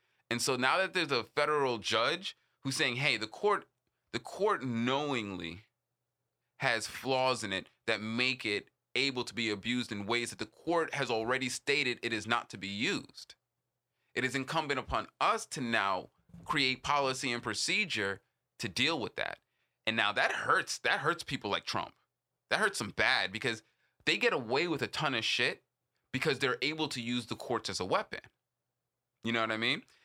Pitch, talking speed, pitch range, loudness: 125 Hz, 185 wpm, 110-135 Hz, -32 LUFS